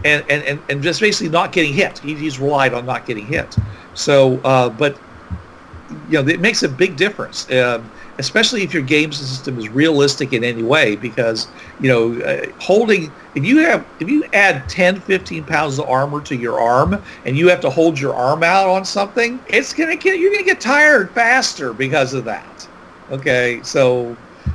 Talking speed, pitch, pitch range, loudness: 195 wpm, 150 Hz, 130-195 Hz, -16 LUFS